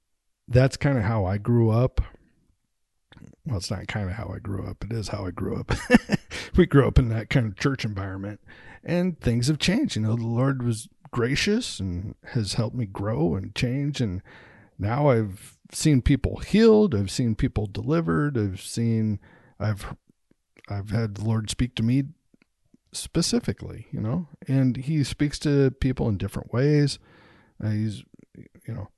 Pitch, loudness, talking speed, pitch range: 115 Hz, -25 LUFS, 170 wpm, 105-140 Hz